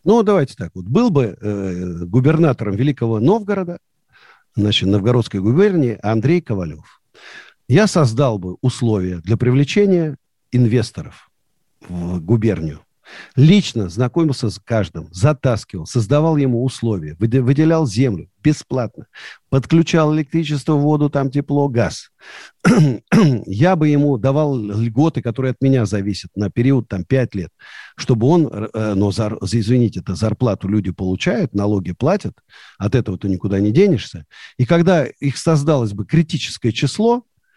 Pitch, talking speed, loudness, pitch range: 125 Hz, 130 wpm, -17 LUFS, 105-150 Hz